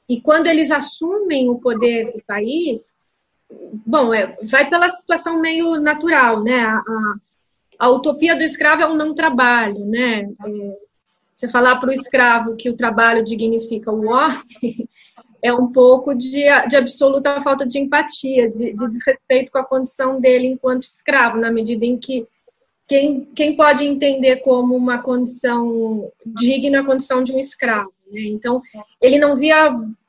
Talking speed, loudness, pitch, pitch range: 155 wpm, -16 LUFS, 255 Hz, 230-285 Hz